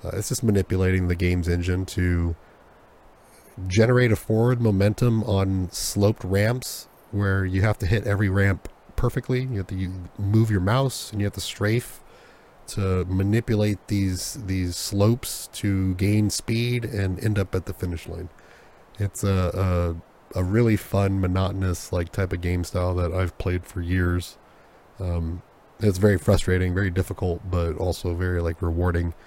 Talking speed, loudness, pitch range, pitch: 160 wpm, -24 LUFS, 90-105 Hz, 95 Hz